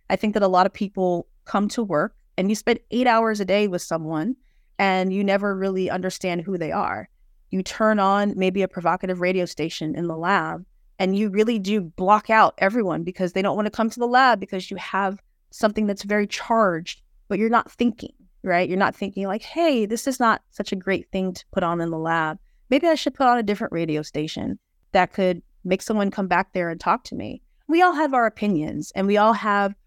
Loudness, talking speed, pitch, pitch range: -22 LUFS, 225 wpm, 195 Hz, 185-220 Hz